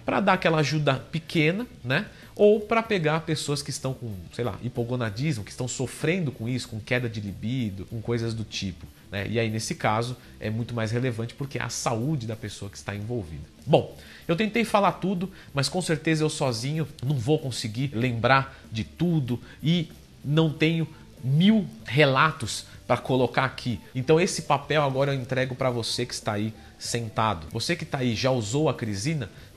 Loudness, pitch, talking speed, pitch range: -26 LUFS, 130 Hz, 185 wpm, 115-155 Hz